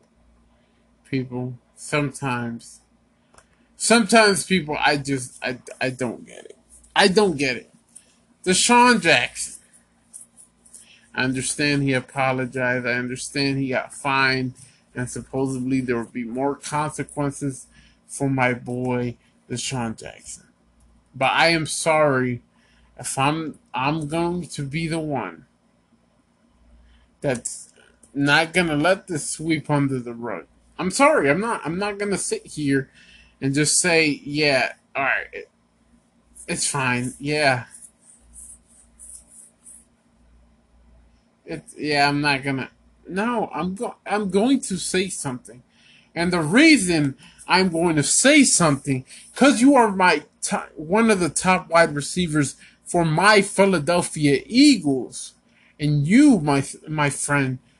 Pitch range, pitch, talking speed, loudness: 125-175 Hz, 145 Hz, 125 wpm, -21 LUFS